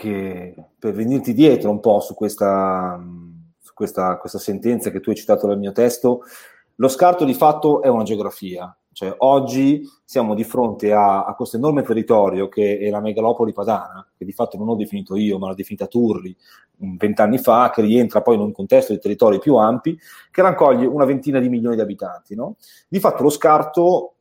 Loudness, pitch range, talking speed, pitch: -18 LUFS, 100-130 Hz, 195 wpm, 105 Hz